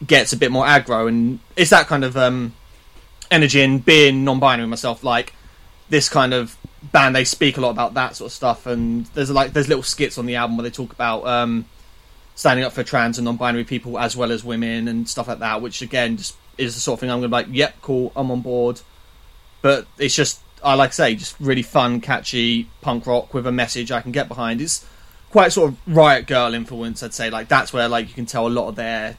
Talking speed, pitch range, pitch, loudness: 240 wpm, 115-130 Hz, 120 Hz, -18 LUFS